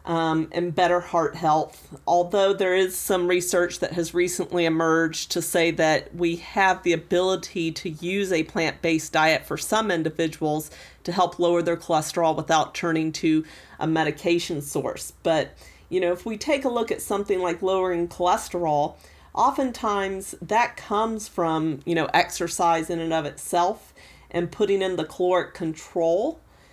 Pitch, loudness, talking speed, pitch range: 175 Hz, -24 LUFS, 160 wpm, 160-185 Hz